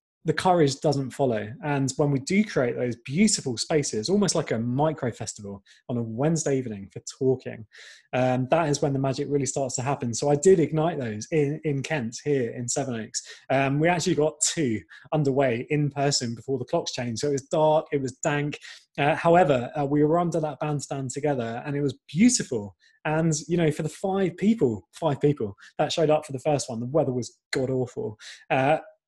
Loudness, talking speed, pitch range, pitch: -25 LUFS, 205 wpm, 125-155 Hz, 145 Hz